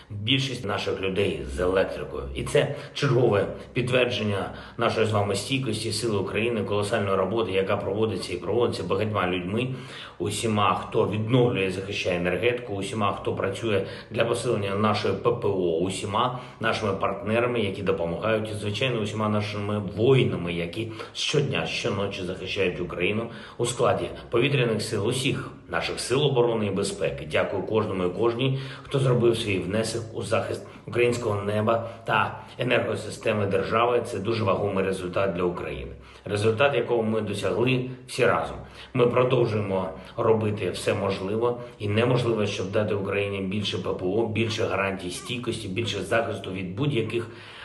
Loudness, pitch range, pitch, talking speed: -26 LUFS, 95-115 Hz, 105 Hz, 135 wpm